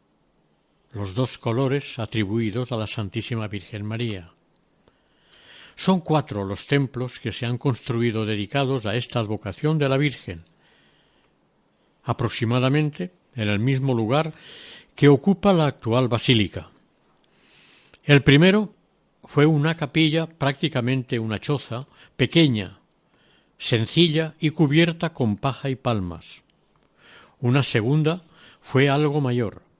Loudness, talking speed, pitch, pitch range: -22 LUFS, 110 wpm, 130 Hz, 110-150 Hz